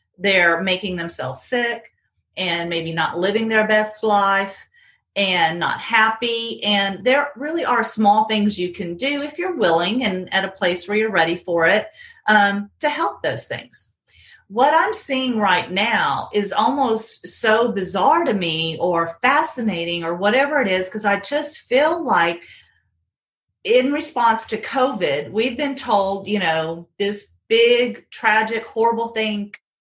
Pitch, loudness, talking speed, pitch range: 215 Hz, -19 LUFS, 155 wpm, 185-255 Hz